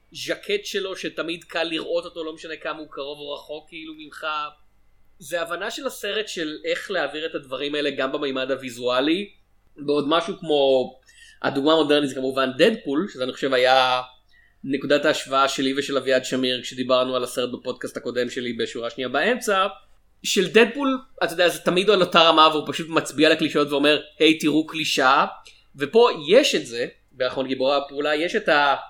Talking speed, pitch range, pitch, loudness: 170 wpm, 130-170 Hz, 150 Hz, -22 LUFS